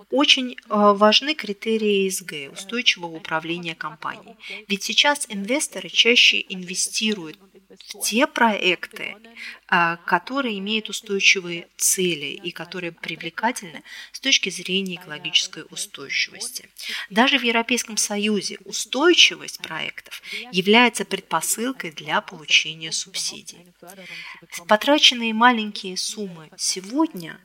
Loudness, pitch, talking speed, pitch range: -20 LUFS, 200 Hz, 90 wpm, 180-230 Hz